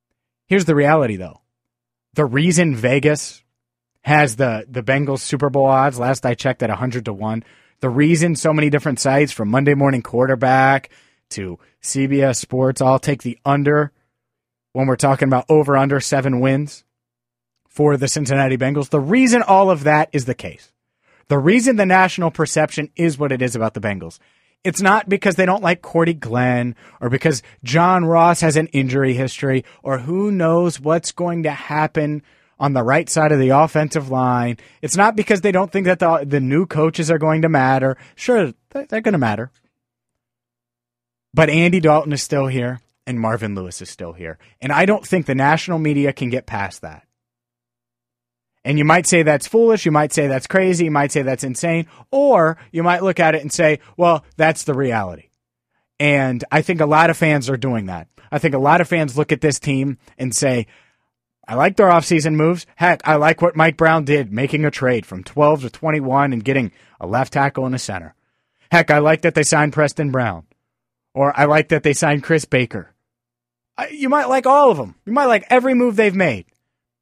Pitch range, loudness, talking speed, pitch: 125-160 Hz, -17 LUFS, 195 wpm, 140 Hz